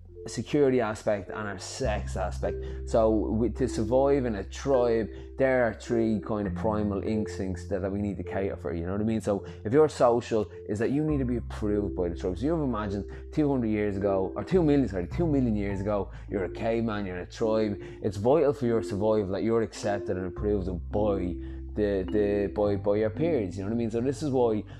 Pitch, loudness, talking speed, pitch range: 105 Hz, -28 LUFS, 230 wpm, 95-115 Hz